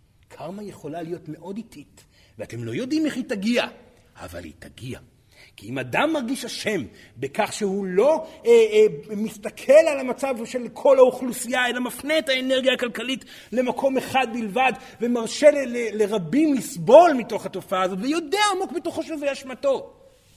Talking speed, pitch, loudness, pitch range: 145 wpm, 250 Hz, -22 LUFS, 205-290 Hz